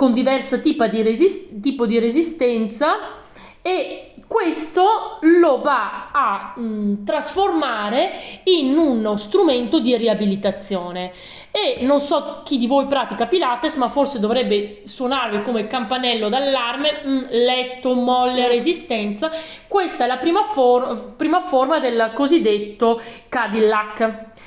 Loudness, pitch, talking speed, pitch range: -19 LUFS, 255 Hz, 120 wpm, 230-310 Hz